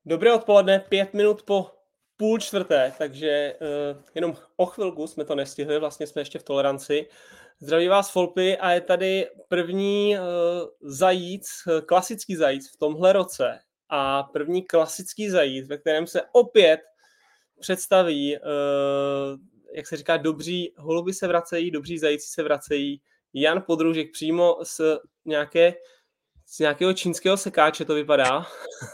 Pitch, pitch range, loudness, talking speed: 170 Hz, 150-190 Hz, -23 LUFS, 135 wpm